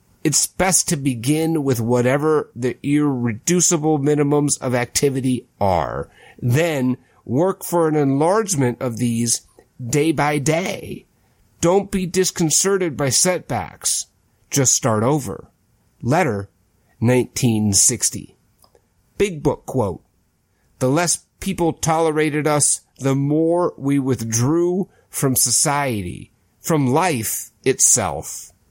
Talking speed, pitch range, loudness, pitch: 100 wpm, 120-160 Hz, -18 LUFS, 140 Hz